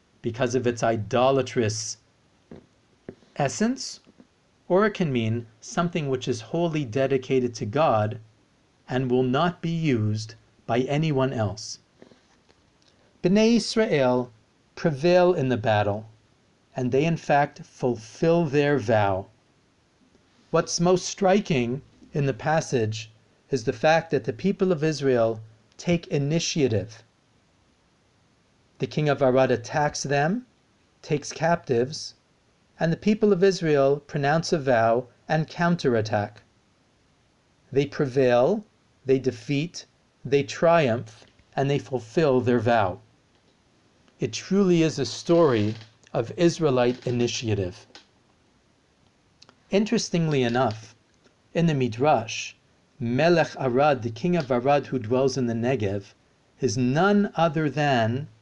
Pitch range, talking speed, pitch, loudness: 115-160 Hz, 115 wpm, 130 Hz, -24 LUFS